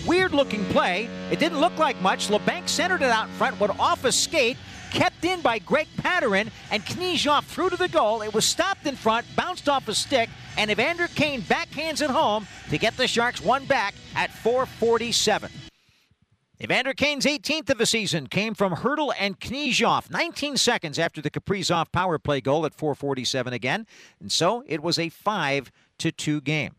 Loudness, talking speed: -24 LUFS, 180 wpm